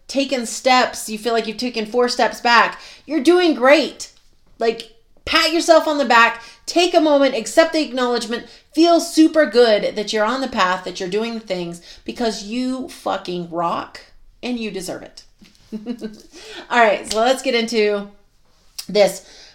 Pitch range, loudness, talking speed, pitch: 215-285 Hz, -17 LUFS, 165 wpm, 235 Hz